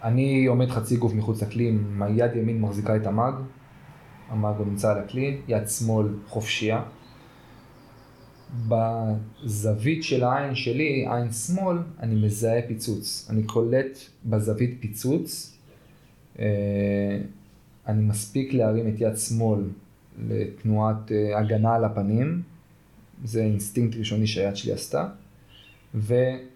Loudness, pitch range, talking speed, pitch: -25 LUFS, 105-130 Hz, 110 wpm, 115 Hz